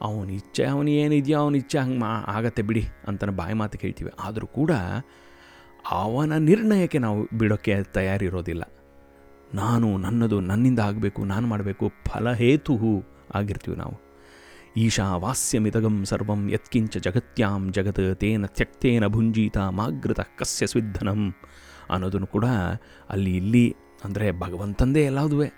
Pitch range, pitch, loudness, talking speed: 95-120 Hz, 105 Hz, -24 LUFS, 110 wpm